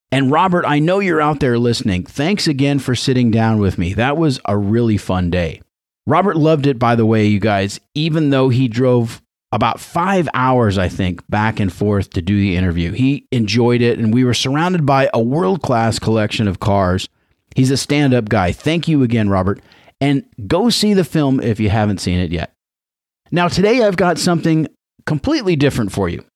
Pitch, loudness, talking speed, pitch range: 120 Hz, -16 LUFS, 200 wpm, 100-145 Hz